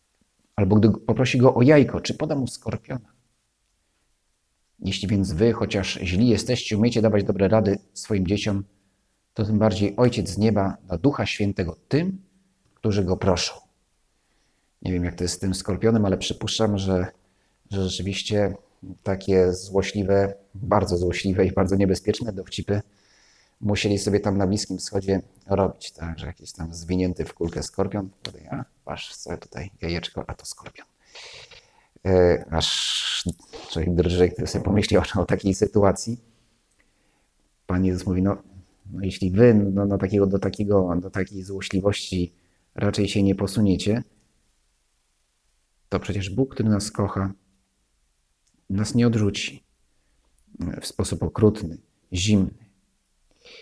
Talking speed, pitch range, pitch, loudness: 135 wpm, 95-105 Hz, 100 Hz, -23 LUFS